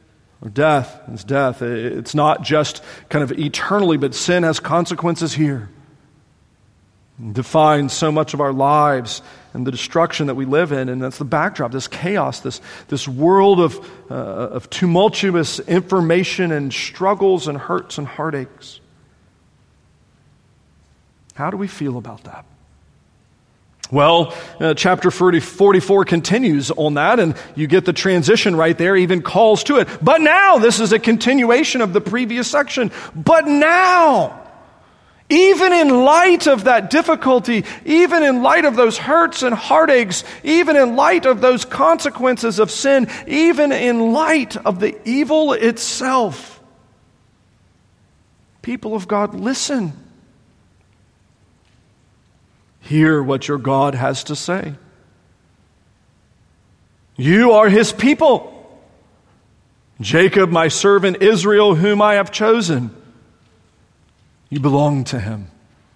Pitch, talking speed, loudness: 165 Hz, 130 wpm, -15 LUFS